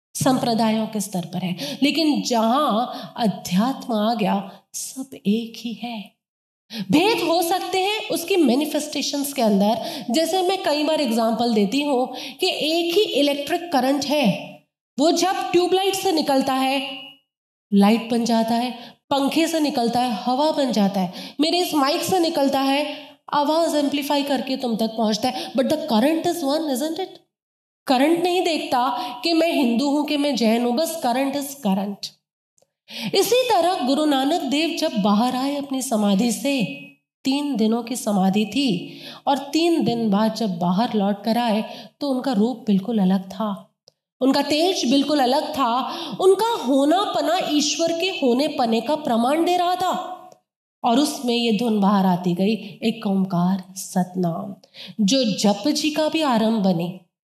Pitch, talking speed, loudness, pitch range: 265 Hz, 160 wpm, -21 LUFS, 220-305 Hz